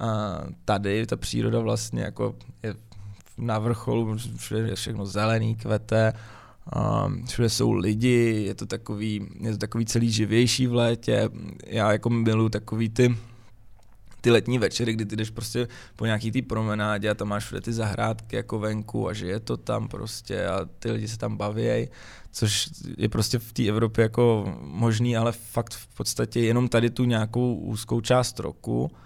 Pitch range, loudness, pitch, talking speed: 105-120 Hz, -26 LUFS, 110 Hz, 170 wpm